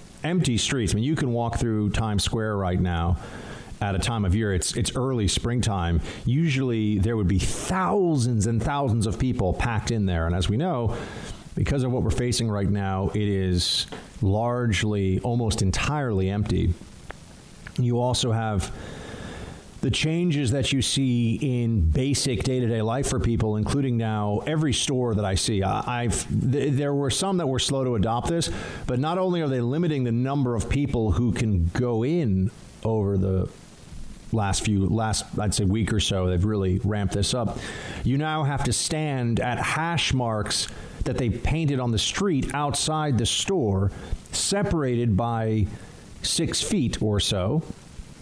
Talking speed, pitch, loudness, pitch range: 170 wpm, 115 Hz, -25 LUFS, 100-130 Hz